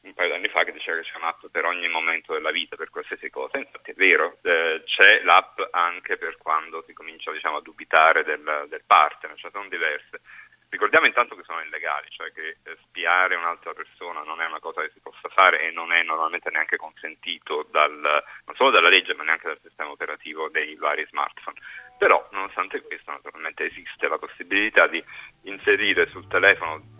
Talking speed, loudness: 195 wpm, -22 LUFS